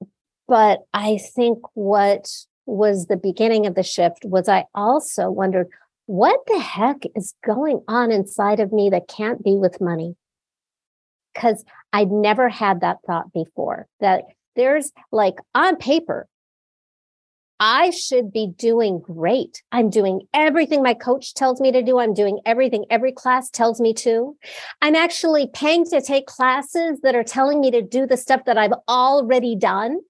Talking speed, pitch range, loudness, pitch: 160 wpm, 205-265 Hz, -19 LUFS, 235 Hz